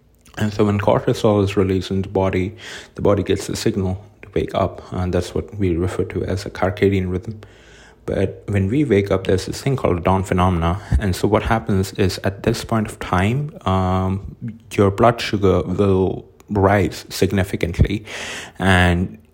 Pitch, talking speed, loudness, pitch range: 95 Hz, 175 wpm, -19 LUFS, 95-105 Hz